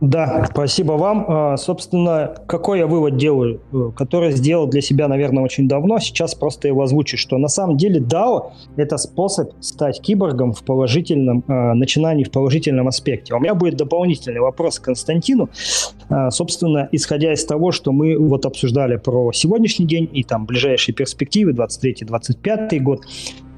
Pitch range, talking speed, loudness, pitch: 130-165 Hz, 150 wpm, -17 LUFS, 145 Hz